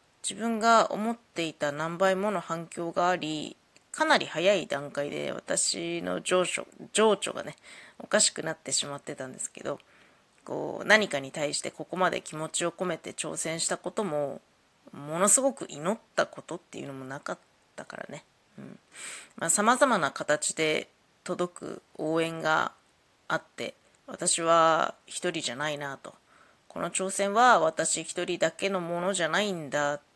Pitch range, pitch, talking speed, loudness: 155-200 Hz, 170 Hz, 295 characters per minute, -28 LUFS